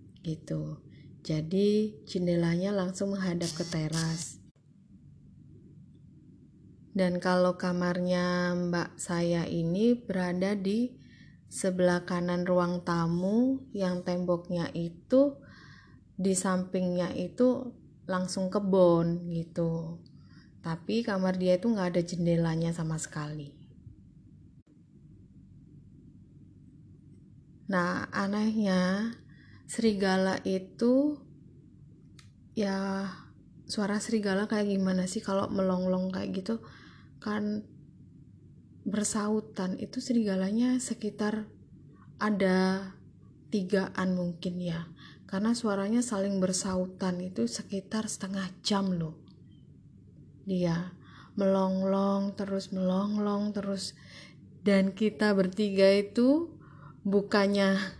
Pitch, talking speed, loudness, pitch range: 190 Hz, 80 wpm, -30 LUFS, 175-205 Hz